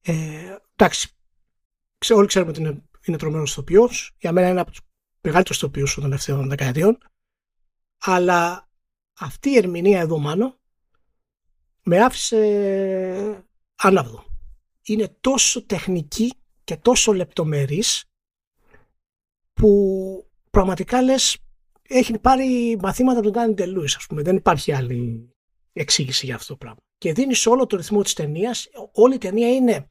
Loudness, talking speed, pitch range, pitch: -20 LUFS, 130 wpm, 155-225 Hz, 190 Hz